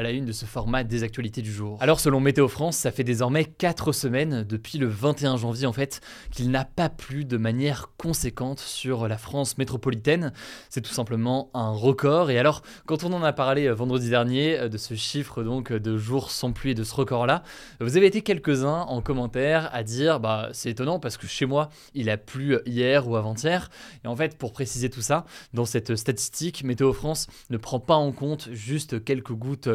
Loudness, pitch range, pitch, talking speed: -26 LUFS, 120-145 Hz, 130 Hz, 210 wpm